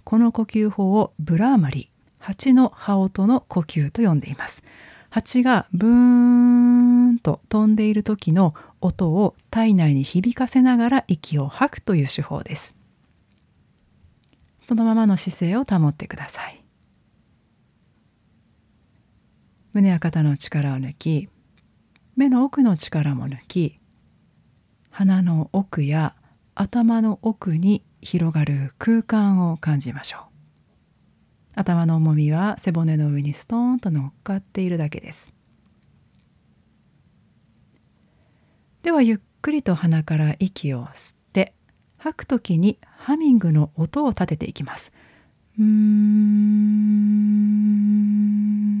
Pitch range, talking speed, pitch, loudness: 155-220 Hz, 215 characters per minute, 195 Hz, -20 LUFS